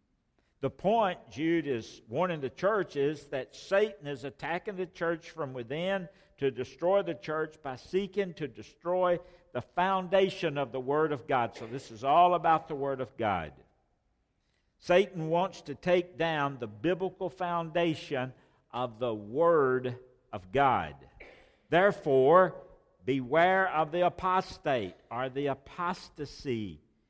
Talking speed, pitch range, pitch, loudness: 135 wpm, 135-180 Hz, 155 Hz, -30 LUFS